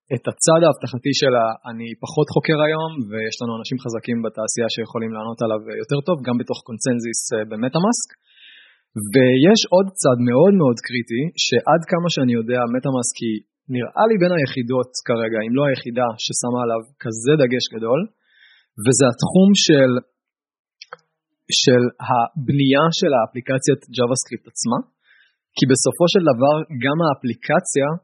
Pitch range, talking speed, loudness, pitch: 120-150 Hz, 135 wpm, -18 LUFS, 130 Hz